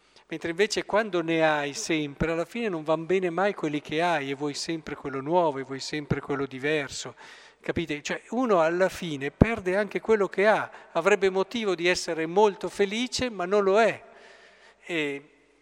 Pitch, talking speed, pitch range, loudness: 175 Hz, 175 wpm, 150-205 Hz, -26 LUFS